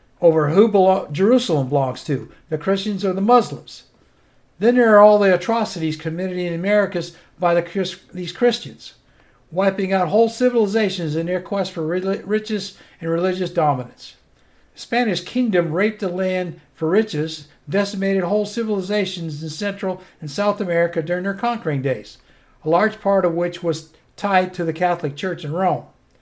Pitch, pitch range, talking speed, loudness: 185 Hz, 165-205 Hz, 160 wpm, -20 LUFS